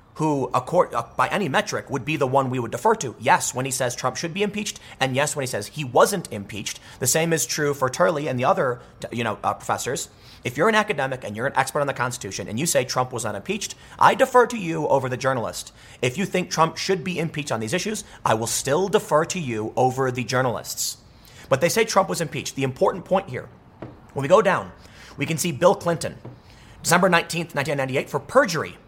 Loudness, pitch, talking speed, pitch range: -23 LUFS, 140 Hz, 220 wpm, 125-170 Hz